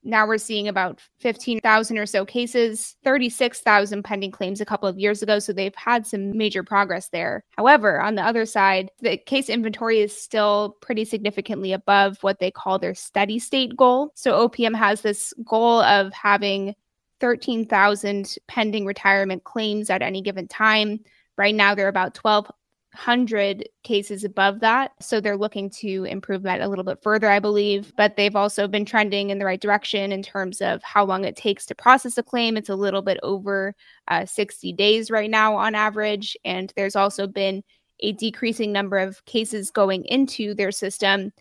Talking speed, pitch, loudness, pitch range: 180 wpm, 205 Hz, -21 LUFS, 195-225 Hz